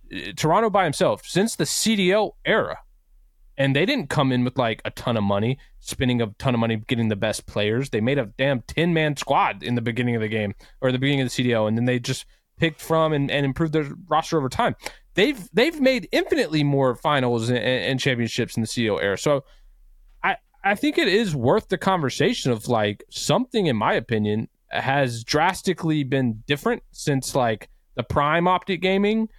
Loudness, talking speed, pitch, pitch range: -22 LUFS, 200 wpm, 135 Hz, 120-165 Hz